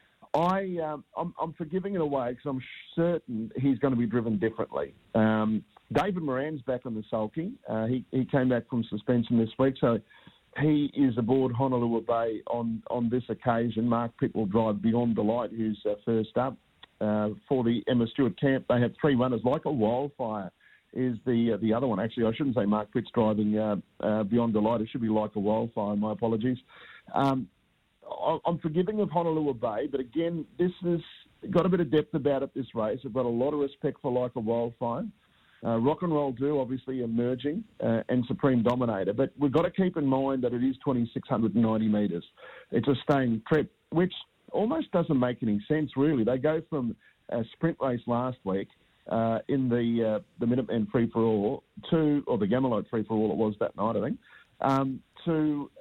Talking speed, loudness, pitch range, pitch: 200 wpm, -28 LUFS, 115-145 Hz, 125 Hz